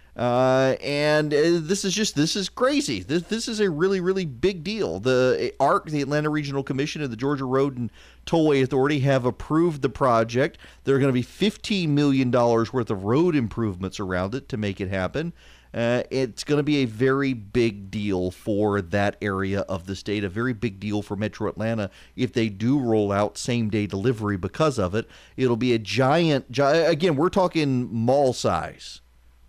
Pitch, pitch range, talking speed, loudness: 130 Hz, 105-150 Hz, 195 wpm, -23 LUFS